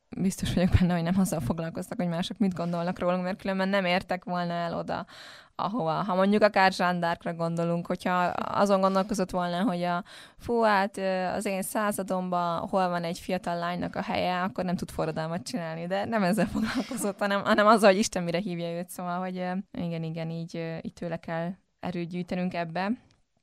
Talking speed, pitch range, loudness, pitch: 180 wpm, 175-195 Hz, -28 LUFS, 180 Hz